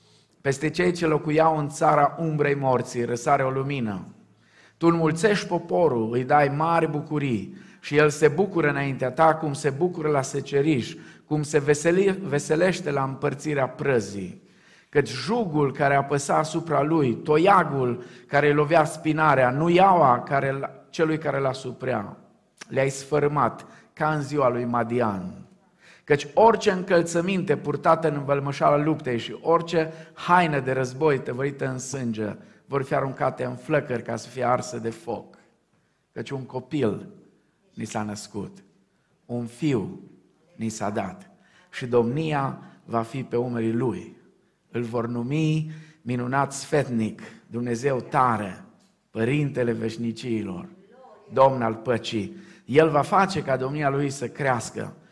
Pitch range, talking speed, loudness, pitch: 125-160 Hz, 135 wpm, -24 LUFS, 140 Hz